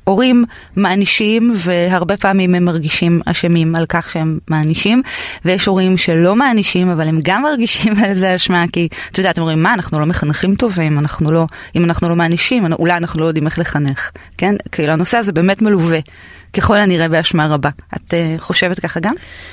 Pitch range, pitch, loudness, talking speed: 165-200 Hz, 175 Hz, -14 LUFS, 180 wpm